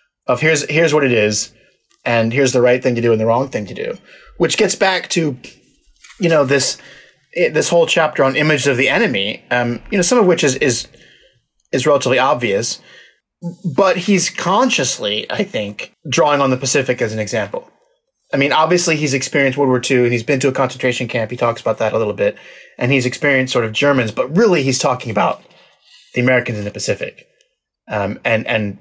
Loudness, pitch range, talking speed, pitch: -16 LUFS, 125-180 Hz, 205 wpm, 140 Hz